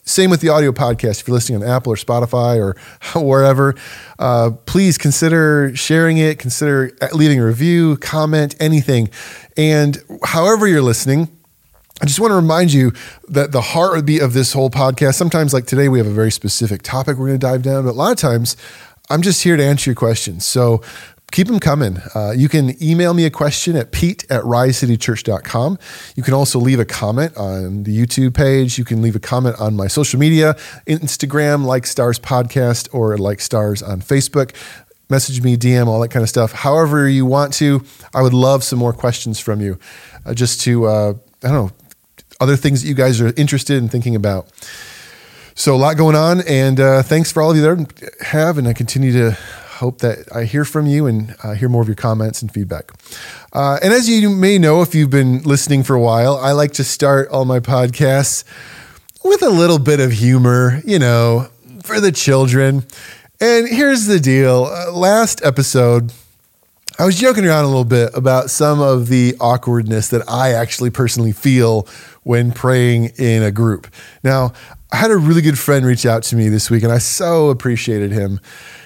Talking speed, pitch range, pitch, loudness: 200 wpm, 120-150 Hz, 130 Hz, -14 LUFS